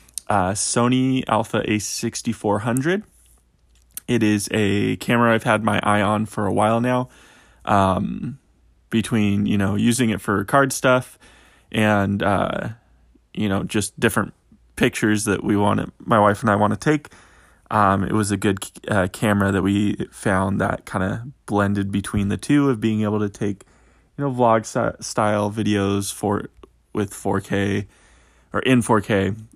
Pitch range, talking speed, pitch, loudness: 100-115 Hz, 155 wpm, 105 Hz, -21 LUFS